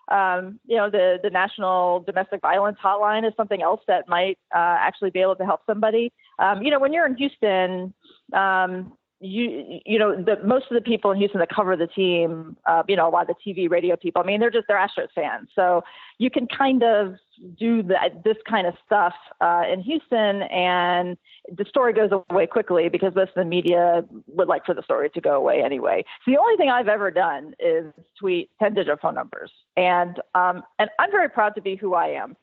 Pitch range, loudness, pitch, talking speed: 180-225 Hz, -22 LUFS, 195 Hz, 215 wpm